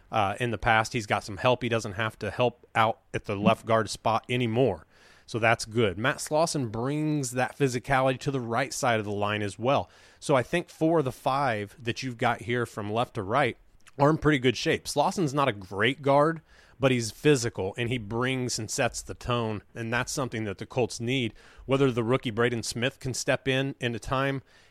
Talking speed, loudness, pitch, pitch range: 220 wpm, -27 LUFS, 120 Hz, 110-135 Hz